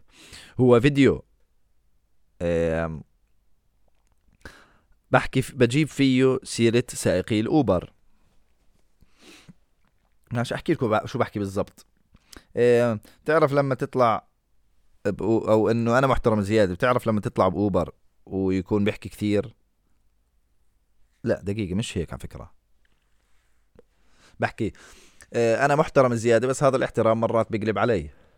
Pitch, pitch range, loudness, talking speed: 110 Hz, 95-120 Hz, -23 LUFS, 95 wpm